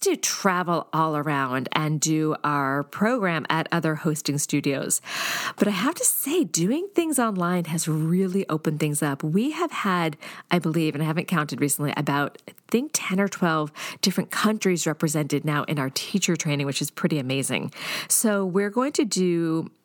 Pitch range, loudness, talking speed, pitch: 150-195 Hz, -24 LUFS, 180 wpm, 160 Hz